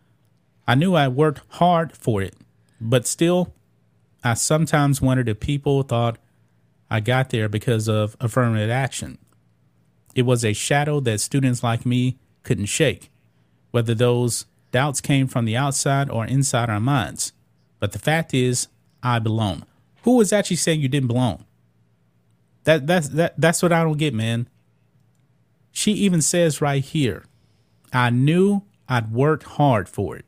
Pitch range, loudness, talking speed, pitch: 110-145 Hz, -21 LUFS, 155 wpm, 125 Hz